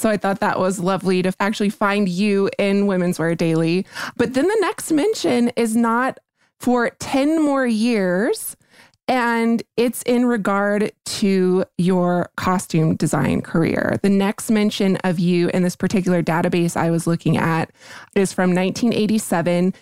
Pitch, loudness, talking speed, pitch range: 200 Hz, -19 LUFS, 150 wpm, 180-230 Hz